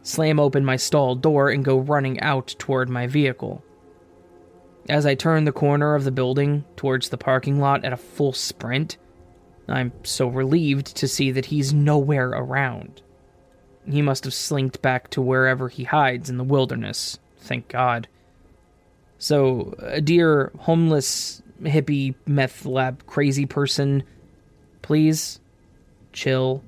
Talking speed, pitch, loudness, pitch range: 140 wpm, 135 Hz, -22 LUFS, 125-145 Hz